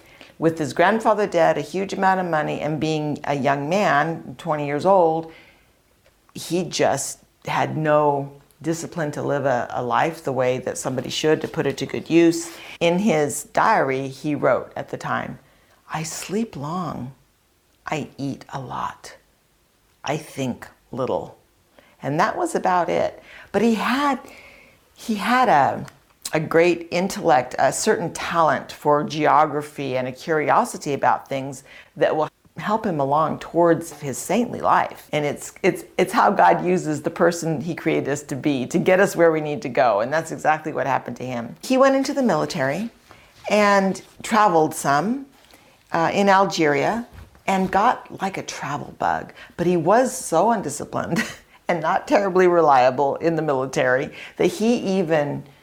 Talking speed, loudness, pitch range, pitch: 160 wpm, -21 LUFS, 145-195 Hz, 160 Hz